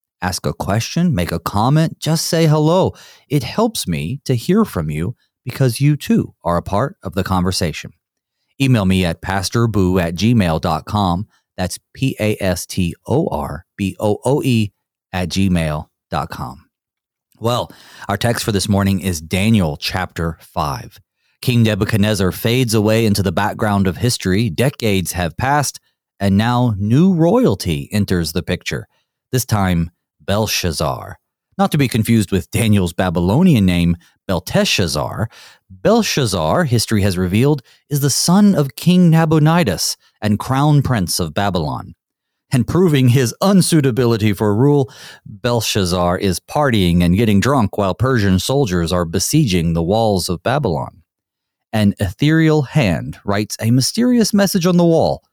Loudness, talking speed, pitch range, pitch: -16 LUFS, 140 wpm, 95-140 Hz, 110 Hz